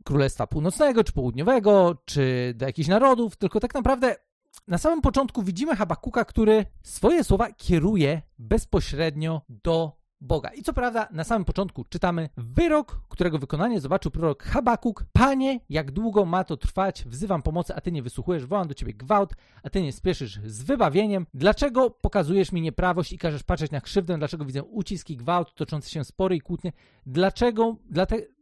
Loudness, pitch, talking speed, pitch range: -25 LUFS, 180 Hz, 165 wpm, 150-215 Hz